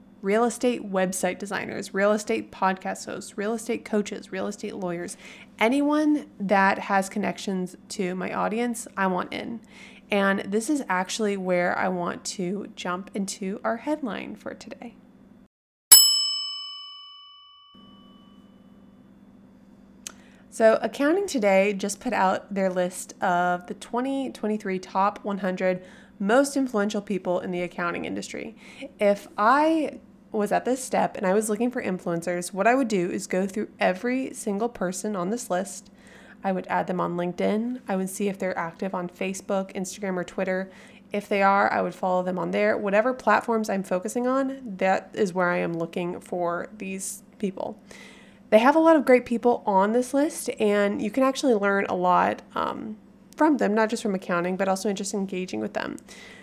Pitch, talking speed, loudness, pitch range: 210 Hz, 165 wpm, -24 LUFS, 190-230 Hz